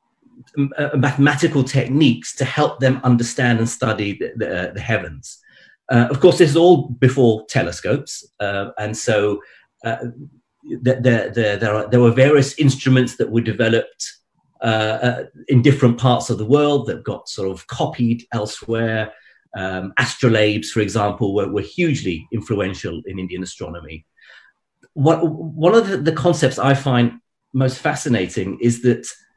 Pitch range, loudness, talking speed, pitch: 110-135 Hz, -18 LUFS, 155 wpm, 120 Hz